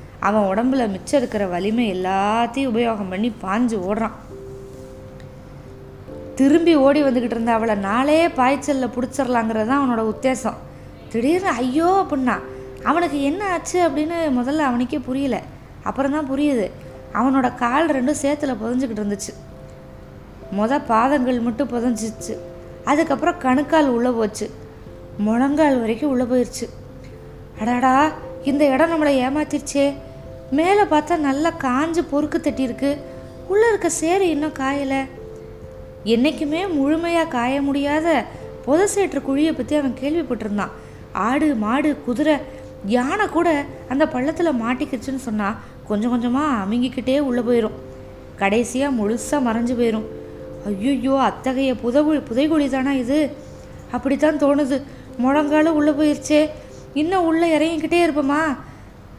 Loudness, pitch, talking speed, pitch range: -20 LUFS, 270 Hz, 110 wpm, 235-300 Hz